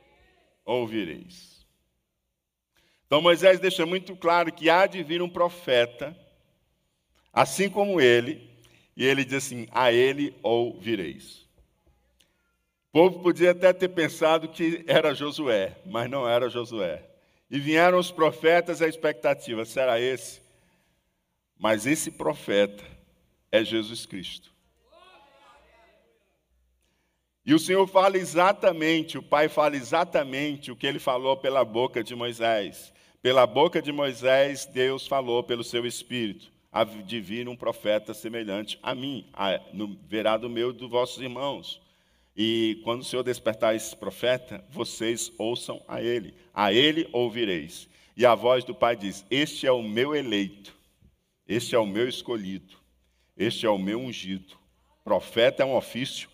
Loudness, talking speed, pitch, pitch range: -25 LUFS, 135 wpm, 125 Hz, 110-160 Hz